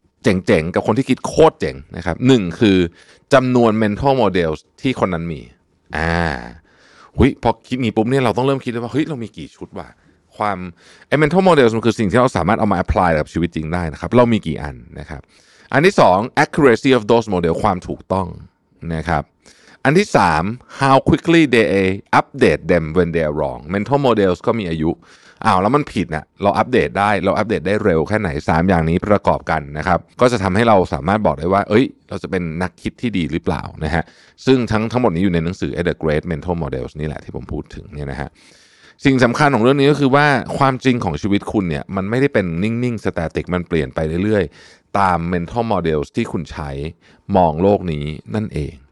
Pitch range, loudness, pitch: 80-120 Hz, -17 LUFS, 95 Hz